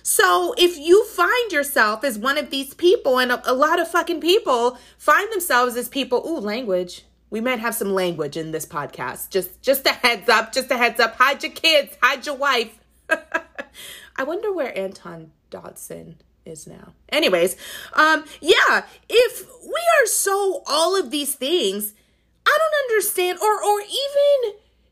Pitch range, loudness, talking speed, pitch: 225-345 Hz, -19 LUFS, 165 wpm, 280 Hz